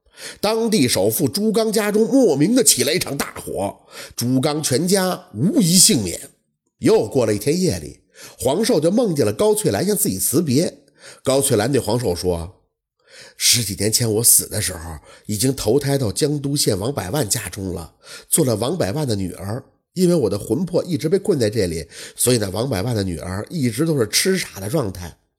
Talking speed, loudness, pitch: 270 characters per minute, -18 LUFS, 130 Hz